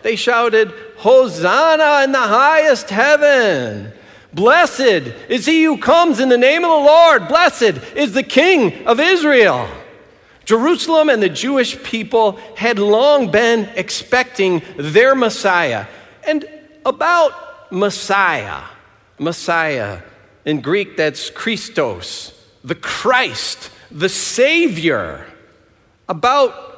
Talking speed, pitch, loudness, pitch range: 110 wpm, 245 Hz, -14 LUFS, 205-305 Hz